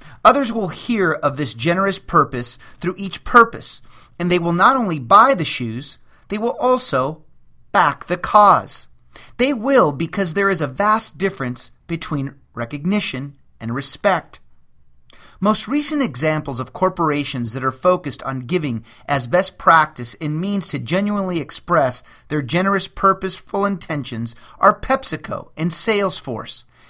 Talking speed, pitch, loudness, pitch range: 140 wpm, 160 Hz, -18 LUFS, 130-195 Hz